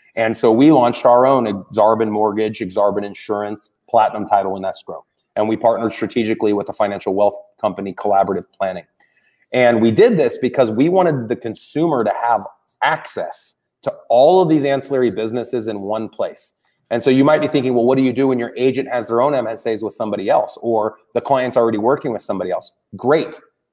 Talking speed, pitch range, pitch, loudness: 195 wpm, 105-130 Hz, 115 Hz, -17 LUFS